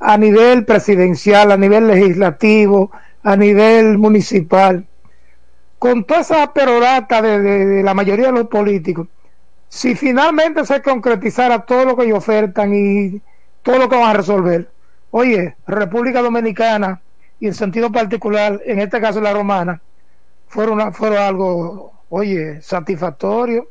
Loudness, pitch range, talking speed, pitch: -13 LUFS, 195-235 Hz, 140 wpm, 210 Hz